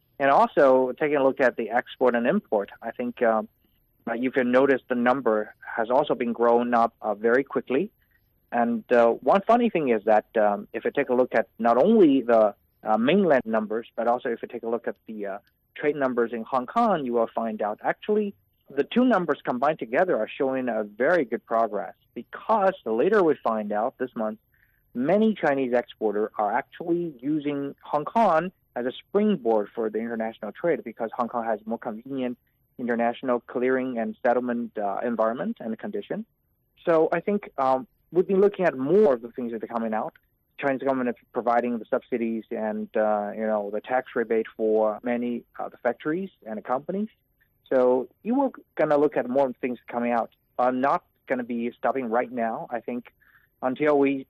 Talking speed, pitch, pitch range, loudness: 195 wpm, 125 Hz, 115-140 Hz, -25 LUFS